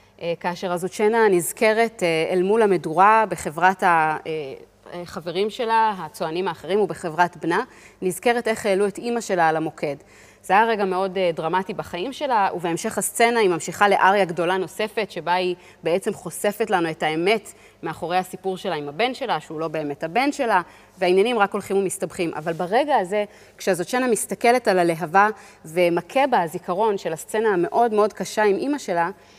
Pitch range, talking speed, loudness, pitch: 175-215 Hz, 155 wpm, -22 LUFS, 190 Hz